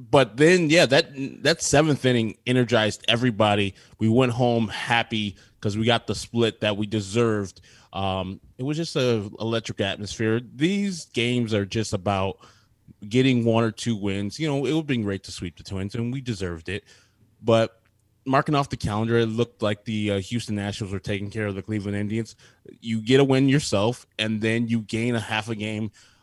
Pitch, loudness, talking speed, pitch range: 115 Hz, -24 LUFS, 195 wpm, 105-125 Hz